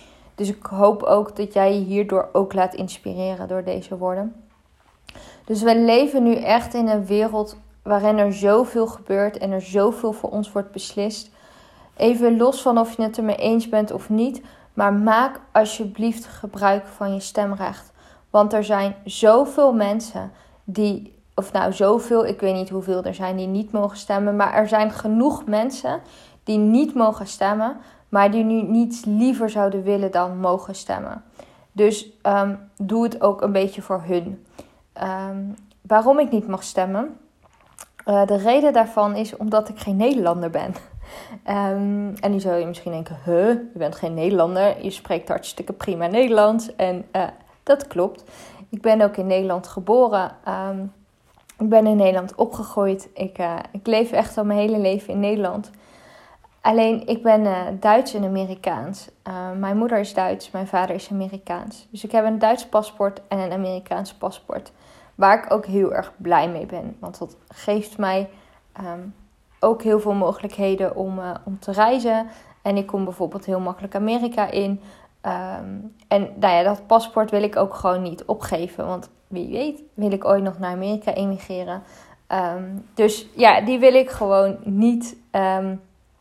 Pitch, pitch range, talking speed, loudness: 205 Hz, 190-220 Hz, 170 wpm, -21 LUFS